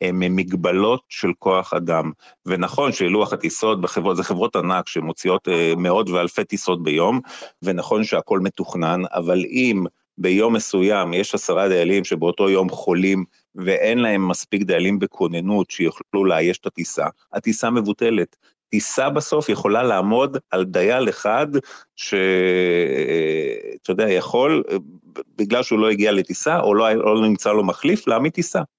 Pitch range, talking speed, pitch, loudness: 90-125 Hz, 135 wpm, 100 Hz, -20 LUFS